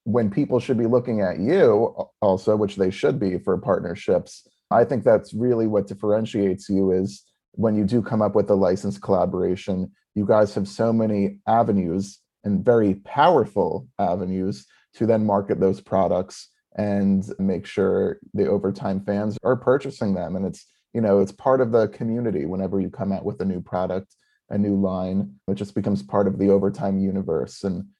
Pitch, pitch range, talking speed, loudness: 100 Hz, 95-110 Hz, 180 wpm, -22 LUFS